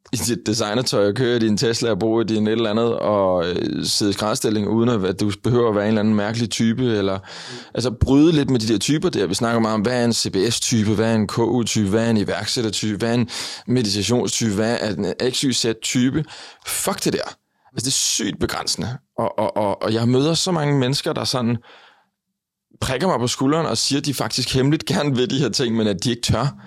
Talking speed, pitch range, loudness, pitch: 225 wpm, 110-130 Hz, -20 LUFS, 115 Hz